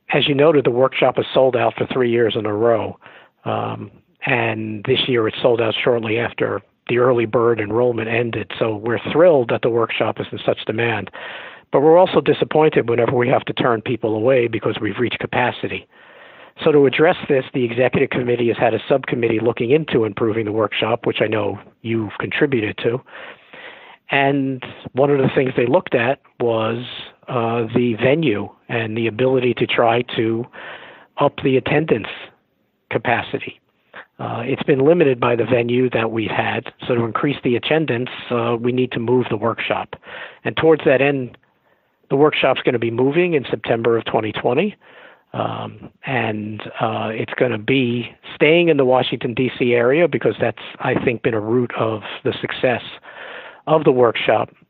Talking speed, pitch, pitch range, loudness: 175 wpm, 120 Hz, 115-130 Hz, -18 LUFS